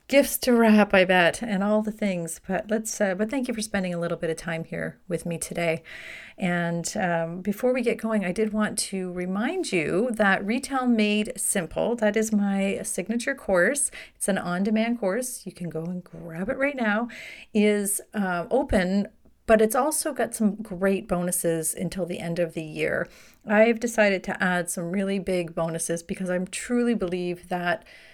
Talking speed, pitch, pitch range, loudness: 190 wpm, 195 Hz, 175-220 Hz, -25 LUFS